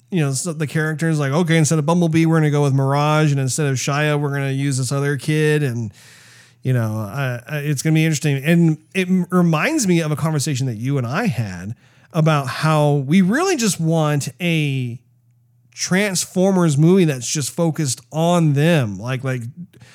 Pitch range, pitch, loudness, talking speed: 135-165 Hz, 150 Hz, -18 LUFS, 190 wpm